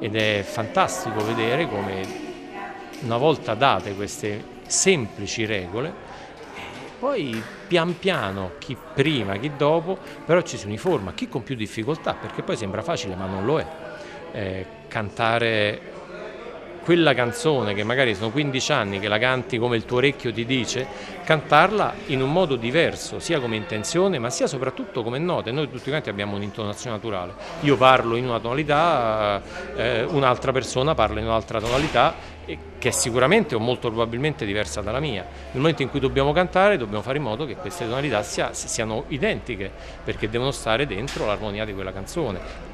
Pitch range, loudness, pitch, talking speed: 105-145 Hz, -23 LUFS, 120 Hz, 165 wpm